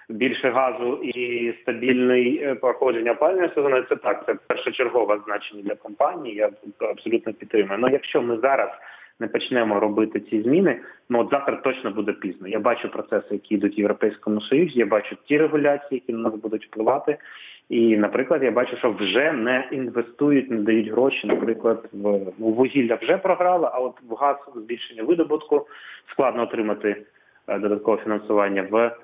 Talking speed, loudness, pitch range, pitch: 160 wpm, -23 LUFS, 105-130 Hz, 115 Hz